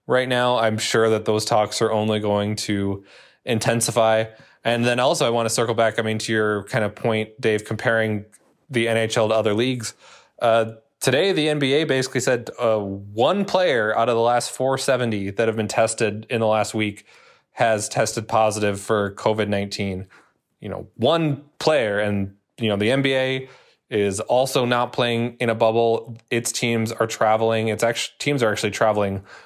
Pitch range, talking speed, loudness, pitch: 105-120 Hz, 180 wpm, -21 LUFS, 115 Hz